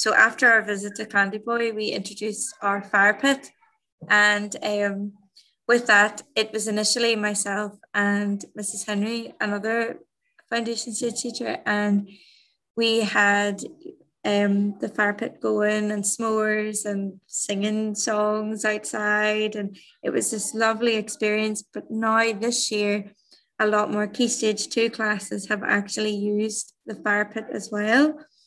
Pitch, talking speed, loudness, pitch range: 215 Hz, 140 wpm, -23 LUFS, 205-225 Hz